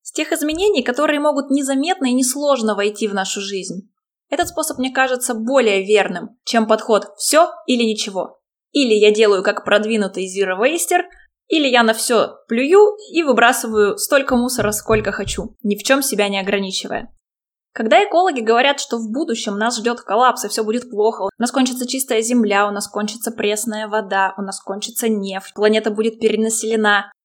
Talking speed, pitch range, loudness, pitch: 165 wpm, 210-265 Hz, -17 LUFS, 225 Hz